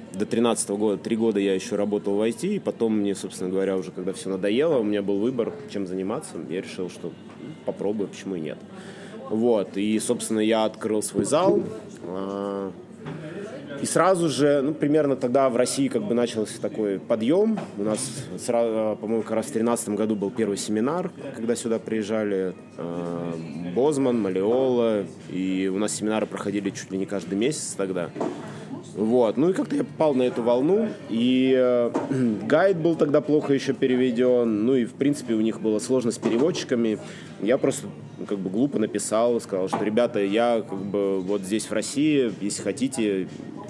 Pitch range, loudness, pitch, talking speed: 100-125 Hz, -24 LUFS, 110 Hz, 170 wpm